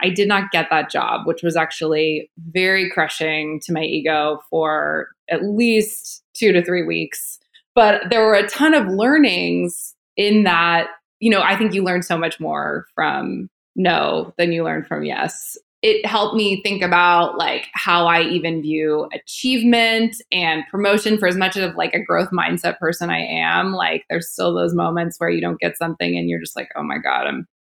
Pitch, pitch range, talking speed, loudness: 175 Hz, 155-205 Hz, 190 wpm, -18 LUFS